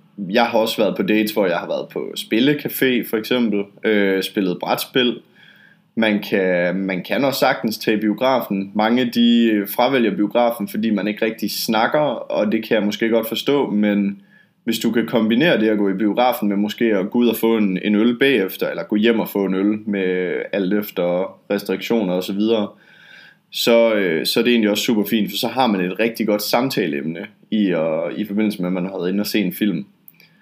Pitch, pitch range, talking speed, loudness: 105 Hz, 100-115 Hz, 205 wpm, -19 LUFS